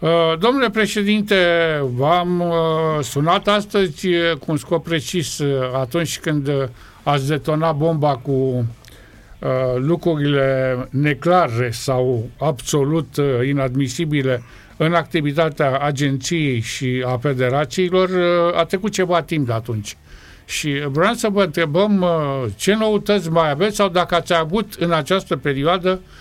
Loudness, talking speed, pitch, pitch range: -19 LUFS, 110 wpm, 155 Hz, 135-175 Hz